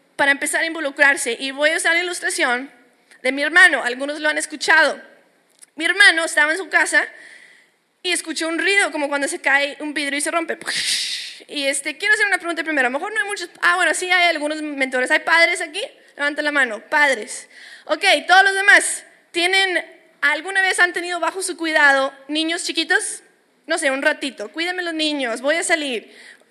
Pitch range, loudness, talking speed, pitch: 290-355 Hz, -18 LUFS, 195 wpm, 320 Hz